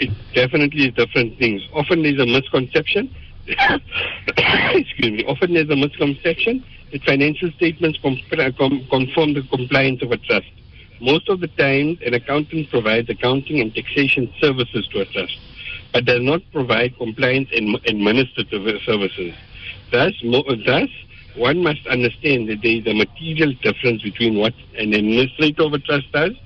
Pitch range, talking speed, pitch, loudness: 120-150 Hz, 155 wpm, 135 Hz, -18 LUFS